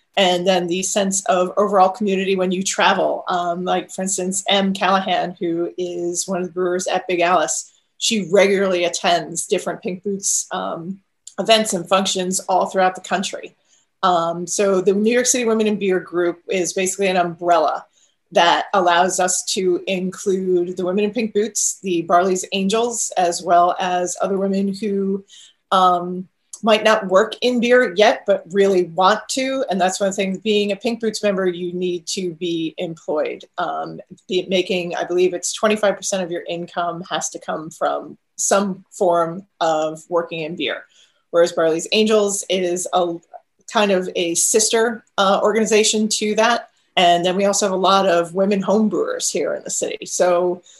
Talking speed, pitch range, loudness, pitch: 175 wpm, 175-200 Hz, -19 LUFS, 185 Hz